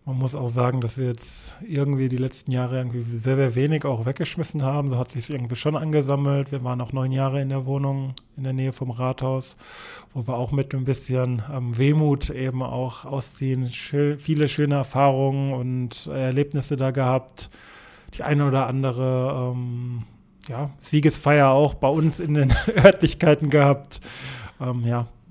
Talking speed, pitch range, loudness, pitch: 175 wpm, 125-145 Hz, -23 LUFS, 135 Hz